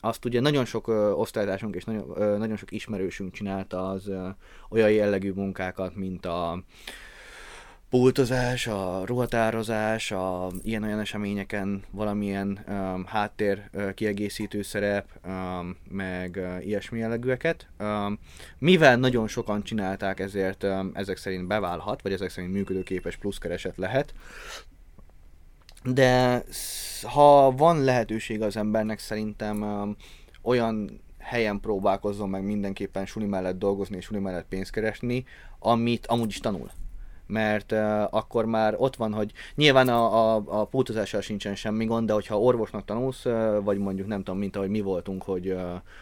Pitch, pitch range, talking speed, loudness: 105 Hz, 95-110 Hz, 135 wpm, -27 LUFS